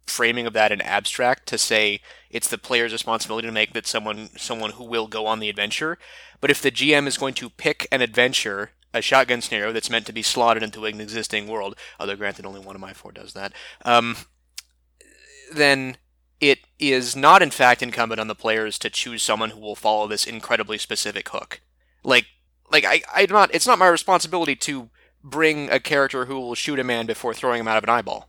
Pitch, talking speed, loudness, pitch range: 115 Hz, 210 wpm, -21 LUFS, 105-130 Hz